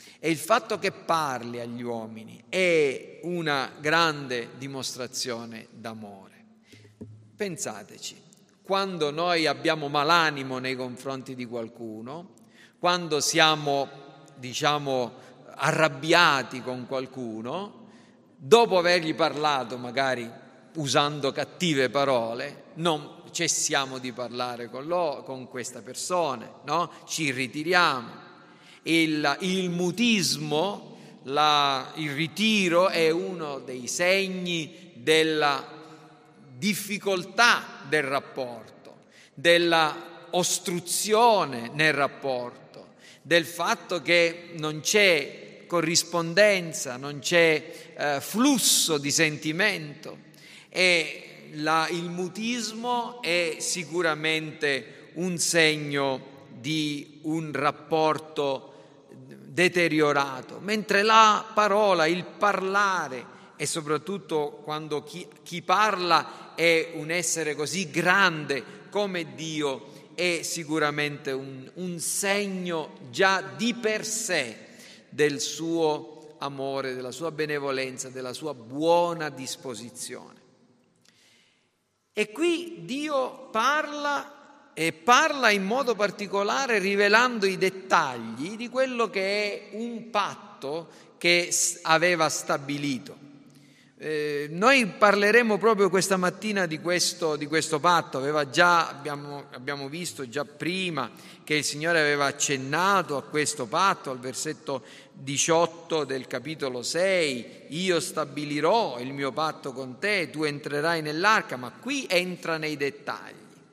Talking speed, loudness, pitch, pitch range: 100 wpm, -25 LUFS, 160 Hz, 140-185 Hz